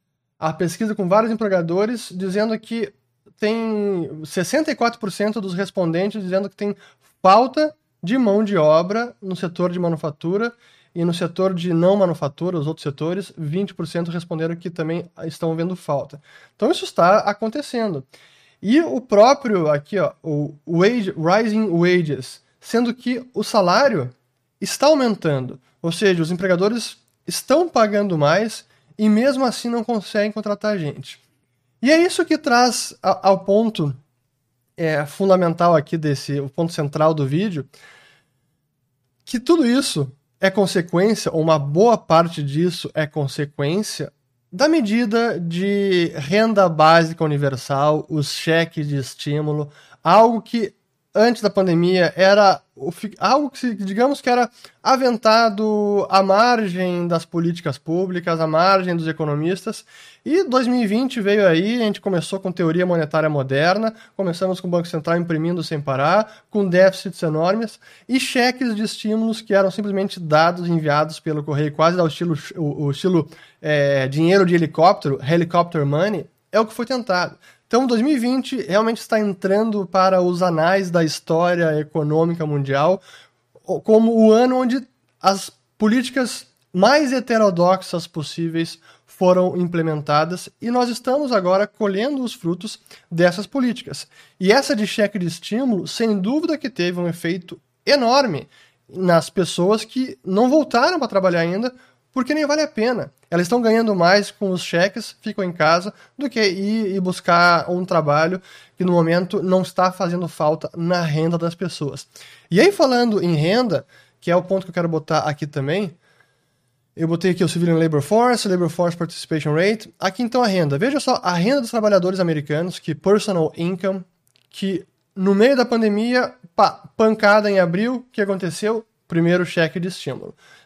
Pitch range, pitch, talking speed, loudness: 160-215 Hz, 185 Hz, 145 wpm, -19 LUFS